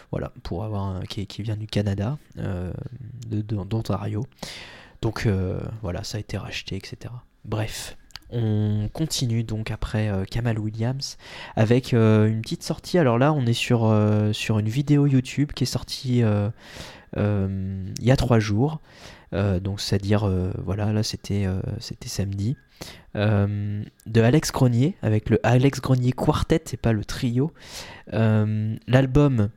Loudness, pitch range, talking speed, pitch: -24 LUFS, 105-125 Hz, 160 wpm, 110 Hz